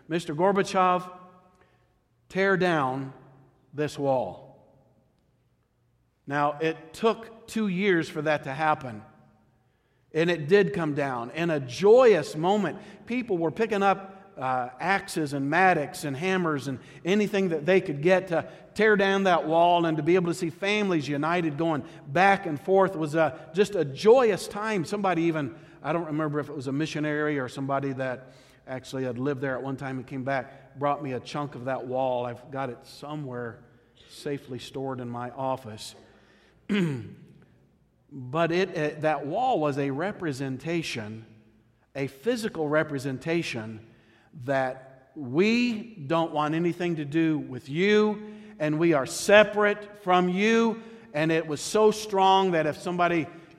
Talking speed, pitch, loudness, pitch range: 150 wpm, 155 Hz, -26 LUFS, 135-185 Hz